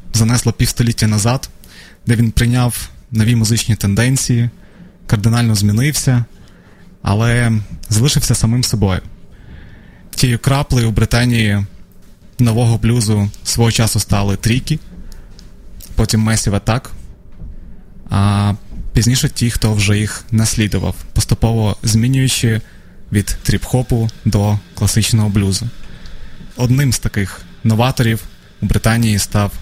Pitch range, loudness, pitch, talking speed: 100-120 Hz, -15 LUFS, 110 Hz, 100 wpm